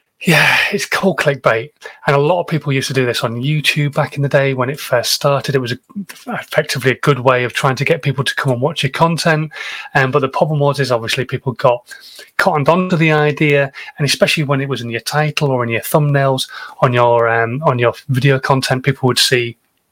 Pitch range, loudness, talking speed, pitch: 130-150 Hz, -15 LUFS, 225 wpm, 140 Hz